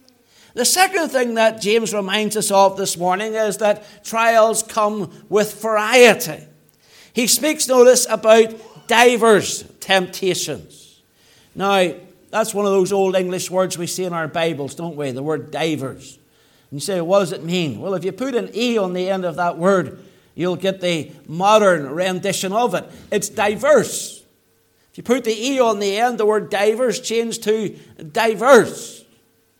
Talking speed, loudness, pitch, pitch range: 165 wpm, -18 LUFS, 200 Hz, 175-220 Hz